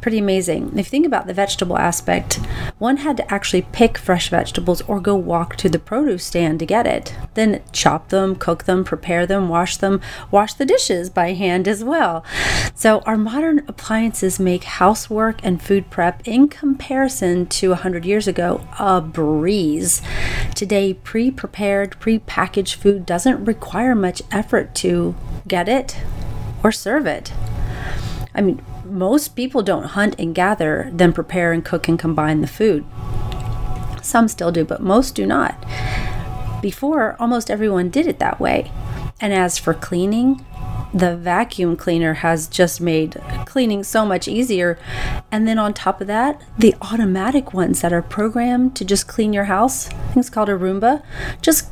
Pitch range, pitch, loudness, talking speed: 170-220 Hz, 190 Hz, -18 LUFS, 165 wpm